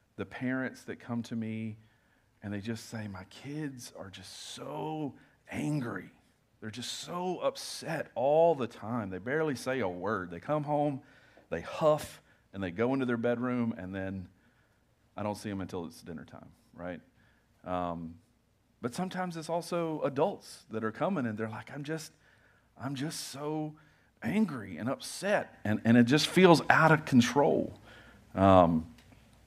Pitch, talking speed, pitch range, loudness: 120 Hz, 160 wpm, 110-150 Hz, -31 LUFS